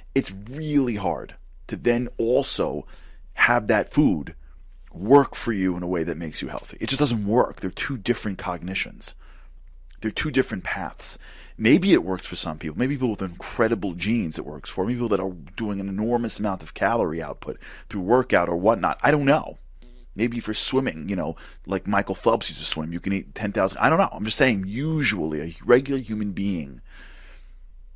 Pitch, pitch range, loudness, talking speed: 100 Hz, 85-120 Hz, -24 LUFS, 195 wpm